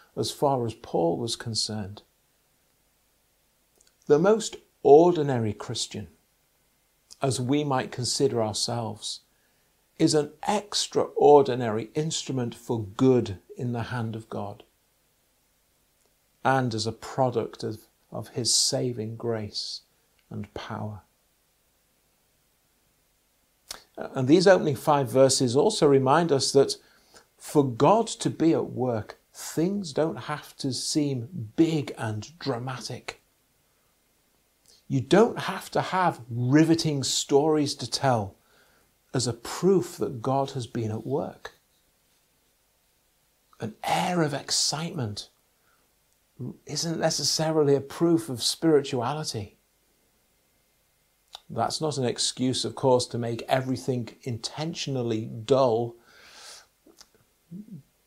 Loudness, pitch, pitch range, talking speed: -25 LUFS, 130 Hz, 115-150 Hz, 100 wpm